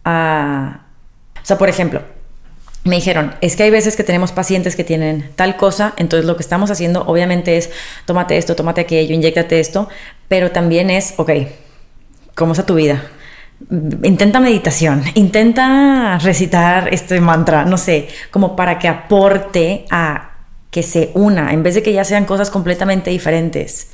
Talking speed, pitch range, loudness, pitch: 160 wpm, 165-195 Hz, -14 LUFS, 175 Hz